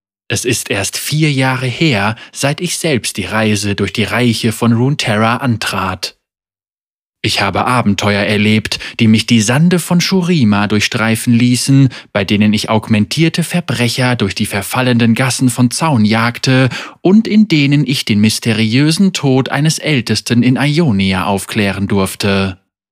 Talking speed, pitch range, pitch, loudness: 140 wpm, 105-135 Hz, 115 Hz, -13 LUFS